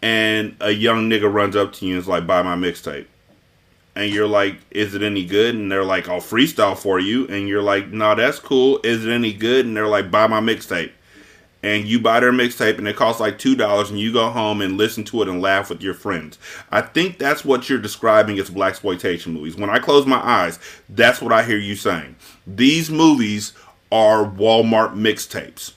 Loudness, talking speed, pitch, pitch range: -18 LUFS, 215 wpm, 105 Hz, 100-115 Hz